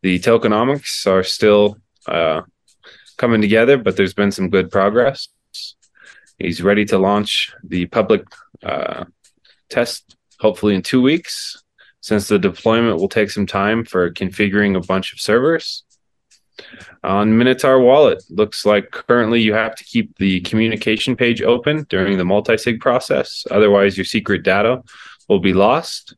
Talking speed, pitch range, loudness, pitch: 145 wpm, 95-115 Hz, -16 LUFS, 105 Hz